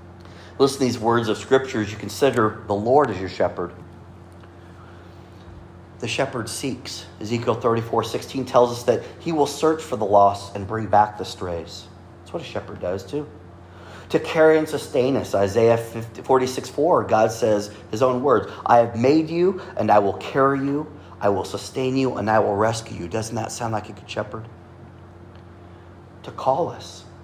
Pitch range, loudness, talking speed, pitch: 90-125 Hz, -22 LUFS, 180 wpm, 110 Hz